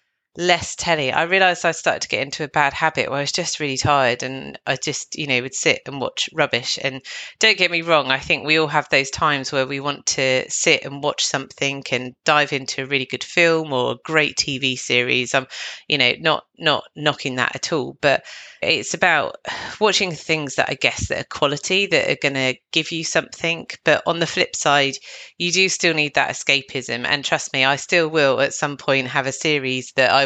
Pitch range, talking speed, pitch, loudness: 135-160 Hz, 220 wpm, 145 Hz, -19 LUFS